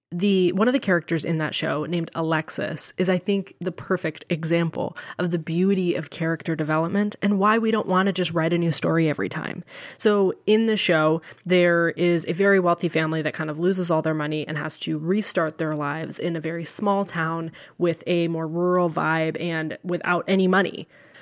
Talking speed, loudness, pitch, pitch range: 205 wpm, -23 LUFS, 170 Hz, 160-185 Hz